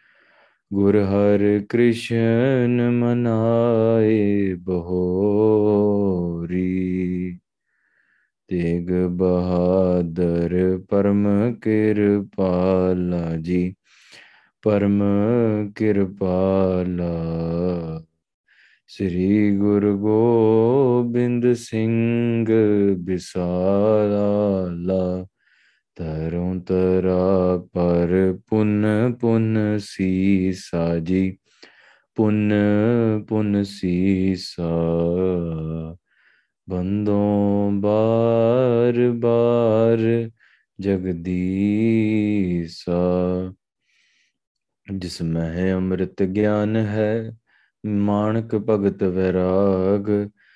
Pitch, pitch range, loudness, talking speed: 100 Hz, 90-110 Hz, -20 LUFS, 45 wpm